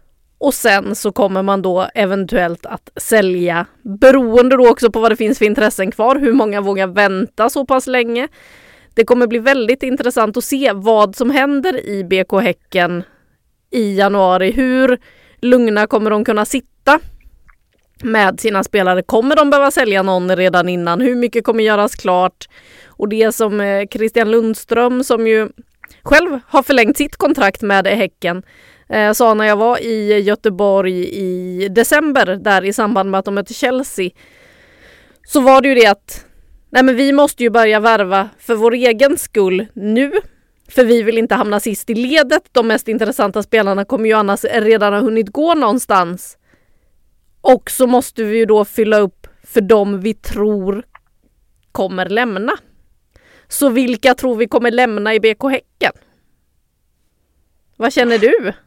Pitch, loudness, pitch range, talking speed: 225 Hz, -14 LUFS, 200-250 Hz, 160 wpm